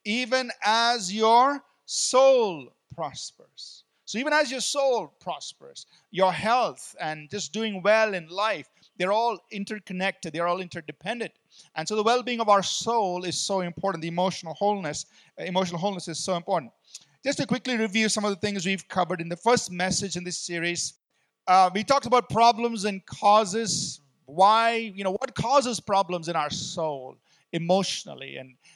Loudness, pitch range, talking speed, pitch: -25 LUFS, 175-225 Hz, 165 wpm, 200 Hz